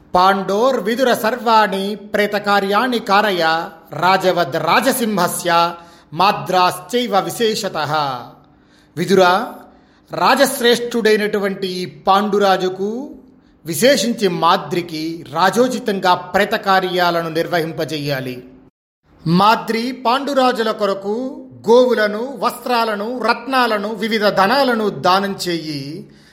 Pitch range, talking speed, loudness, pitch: 175-230 Hz, 55 wpm, -16 LUFS, 200 Hz